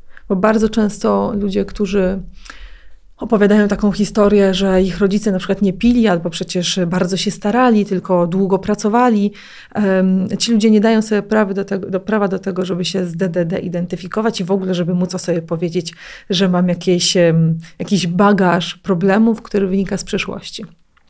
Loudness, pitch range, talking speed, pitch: -16 LUFS, 180-210 Hz, 160 wpm, 195 Hz